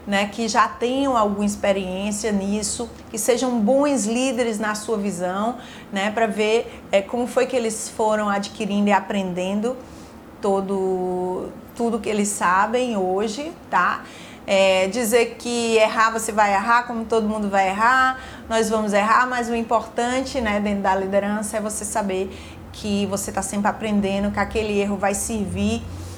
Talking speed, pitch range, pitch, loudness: 155 wpm, 200-235 Hz, 215 Hz, -21 LUFS